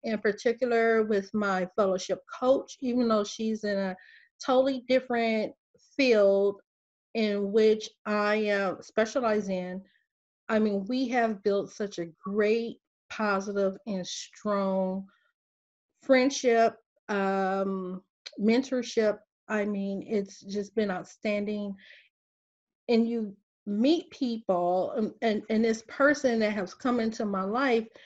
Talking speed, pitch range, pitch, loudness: 120 wpm, 195-230 Hz, 215 Hz, -28 LUFS